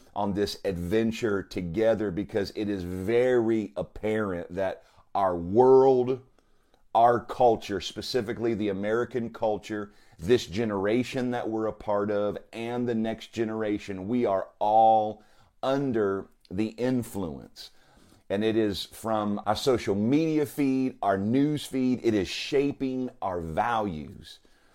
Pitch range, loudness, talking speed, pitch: 100-125 Hz, -27 LUFS, 125 wpm, 110 Hz